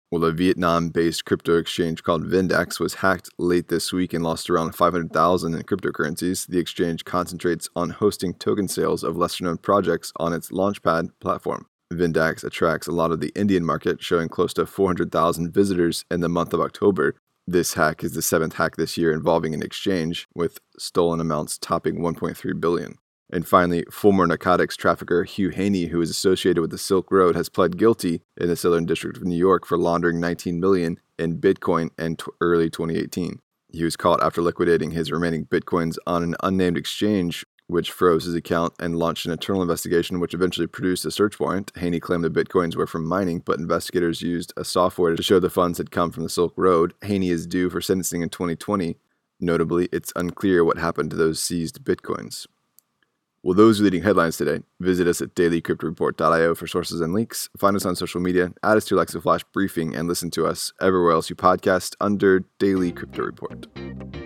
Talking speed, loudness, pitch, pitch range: 190 wpm, -22 LUFS, 85 Hz, 85-90 Hz